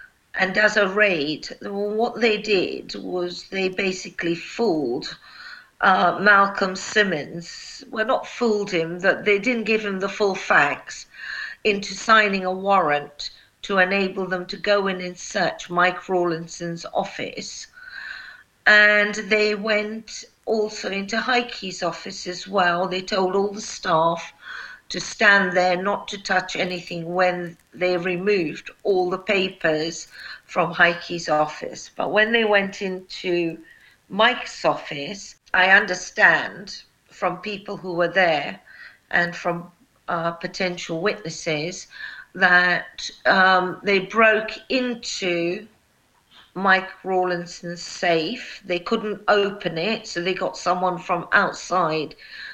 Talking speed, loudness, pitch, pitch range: 125 wpm, -21 LUFS, 190 Hz, 175-210 Hz